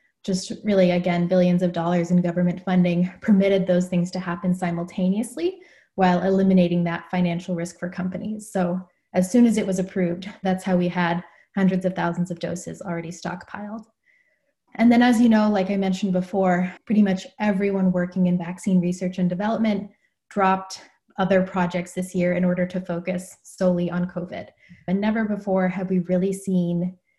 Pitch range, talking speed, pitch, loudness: 180-200 Hz, 170 wpm, 185 Hz, -23 LUFS